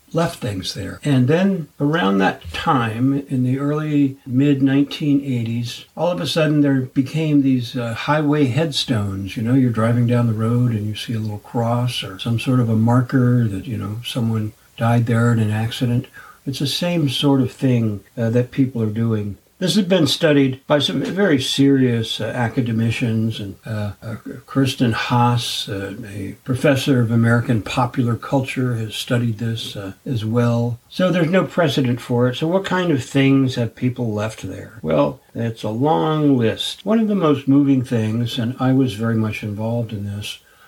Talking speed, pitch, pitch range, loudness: 185 wpm, 125 Hz, 115-140 Hz, -19 LUFS